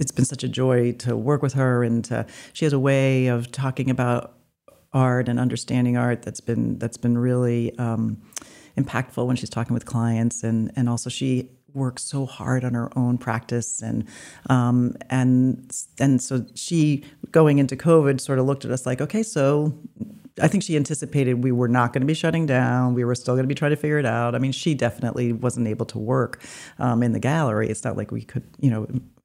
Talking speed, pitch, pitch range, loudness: 215 wpm, 125 Hz, 120-135 Hz, -23 LUFS